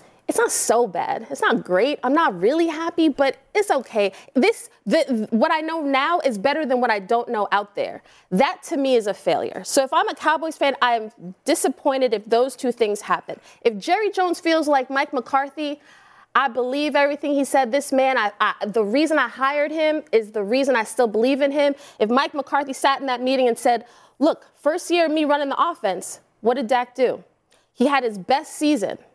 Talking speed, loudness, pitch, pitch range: 215 wpm, -21 LUFS, 275 Hz, 245-310 Hz